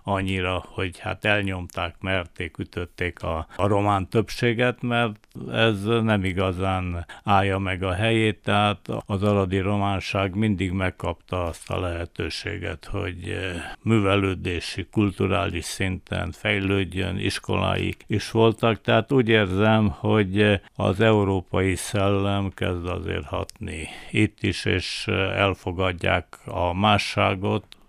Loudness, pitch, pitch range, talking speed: -24 LUFS, 100 Hz, 95-105 Hz, 110 wpm